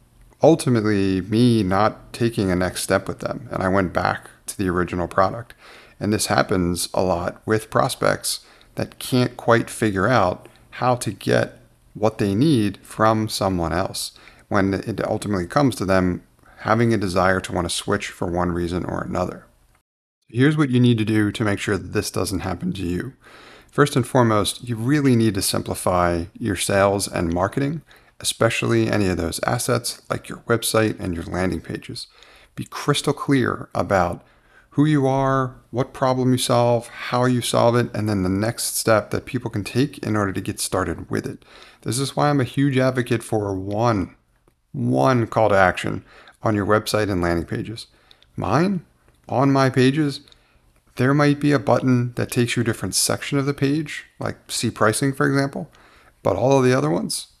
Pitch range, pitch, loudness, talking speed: 95-125 Hz, 110 Hz, -21 LUFS, 185 wpm